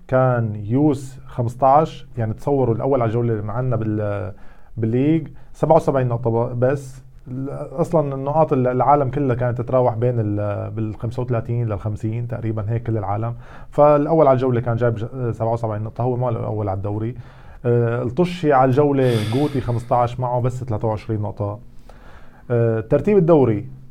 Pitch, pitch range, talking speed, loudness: 120 Hz, 115-135 Hz, 130 wpm, -20 LUFS